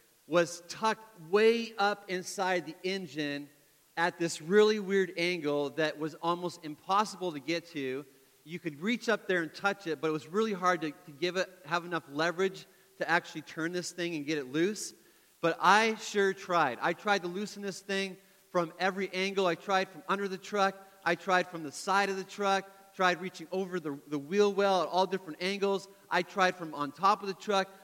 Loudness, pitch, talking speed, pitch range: -31 LUFS, 180 Hz, 205 wpm, 165-195 Hz